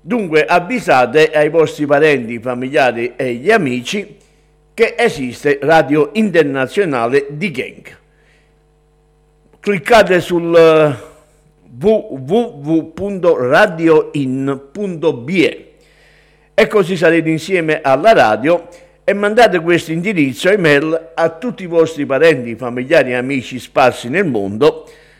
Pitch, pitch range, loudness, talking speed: 155 Hz, 145-185 Hz, -14 LUFS, 95 wpm